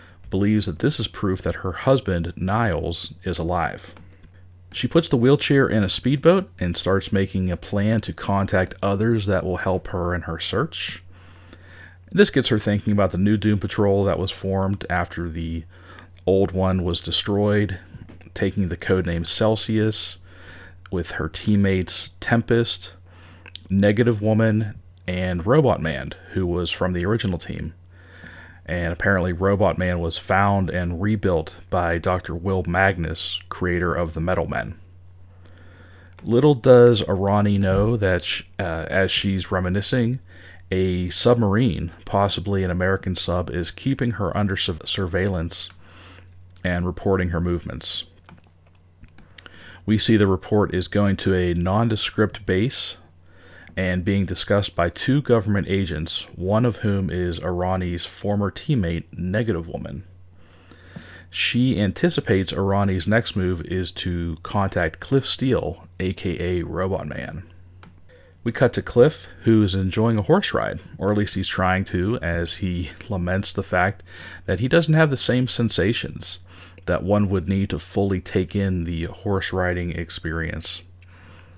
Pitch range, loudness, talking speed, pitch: 90-100 Hz, -22 LUFS, 140 wpm, 95 Hz